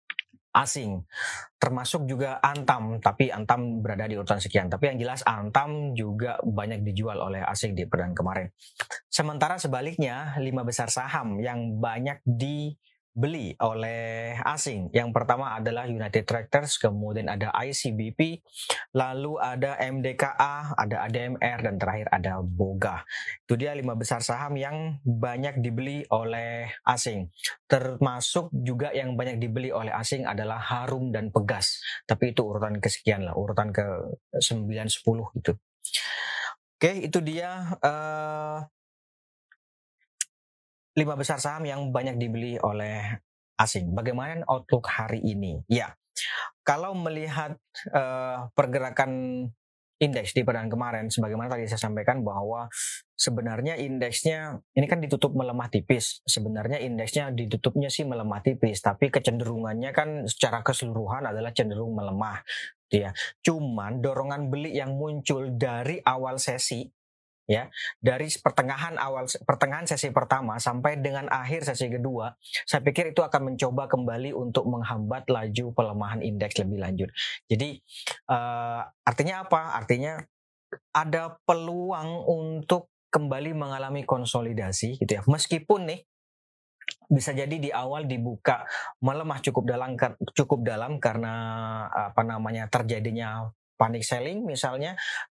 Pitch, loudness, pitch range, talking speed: 125 Hz, -28 LUFS, 110-140 Hz, 125 wpm